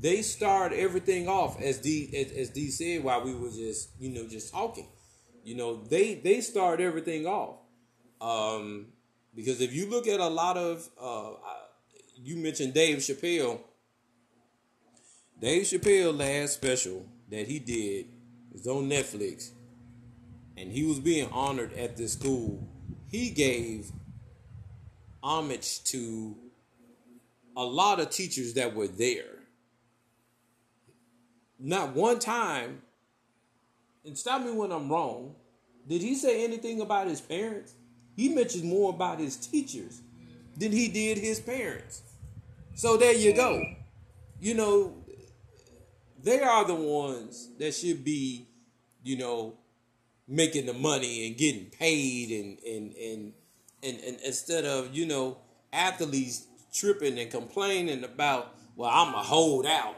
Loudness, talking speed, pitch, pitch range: -29 LUFS, 135 wpm, 125 Hz, 120-165 Hz